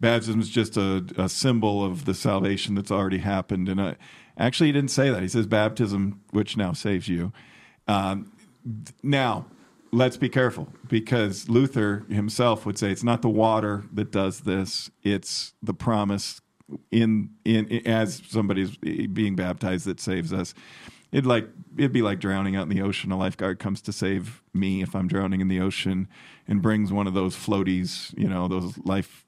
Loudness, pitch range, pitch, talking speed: -25 LUFS, 95-115 Hz, 100 Hz, 180 wpm